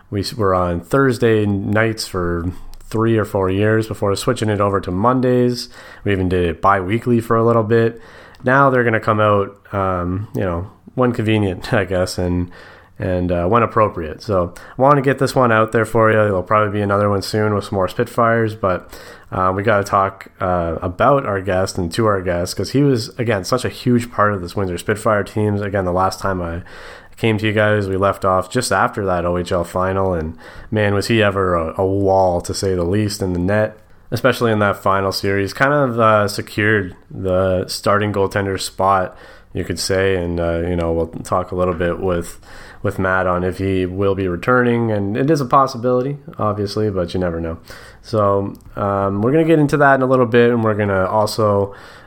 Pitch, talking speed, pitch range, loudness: 100 Hz, 215 wpm, 95-115 Hz, -17 LUFS